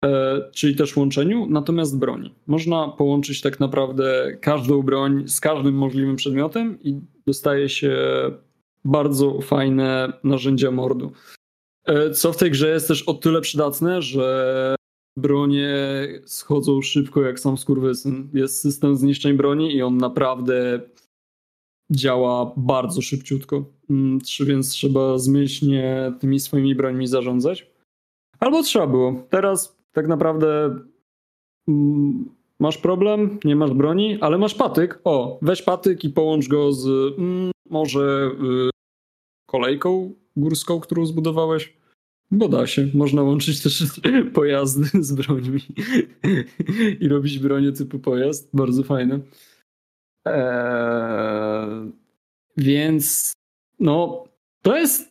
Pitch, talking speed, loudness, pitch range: 140 Hz, 115 wpm, -20 LUFS, 135-155 Hz